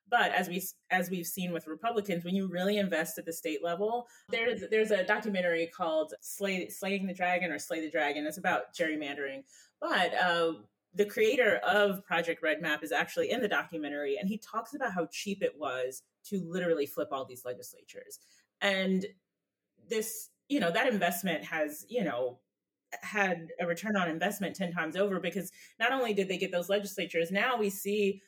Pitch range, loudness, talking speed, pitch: 160-205 Hz, -32 LUFS, 185 wpm, 180 Hz